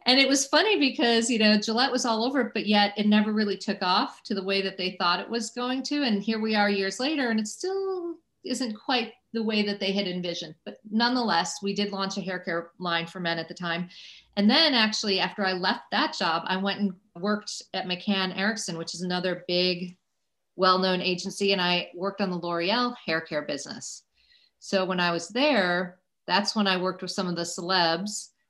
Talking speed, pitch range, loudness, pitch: 220 wpm, 180-230 Hz, -26 LUFS, 200 Hz